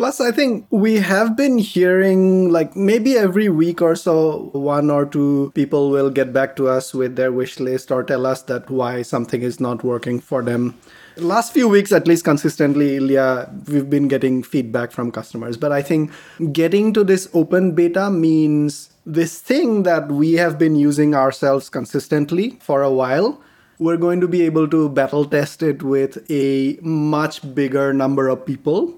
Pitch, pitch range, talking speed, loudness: 150 Hz, 135-170 Hz, 180 wpm, -17 LUFS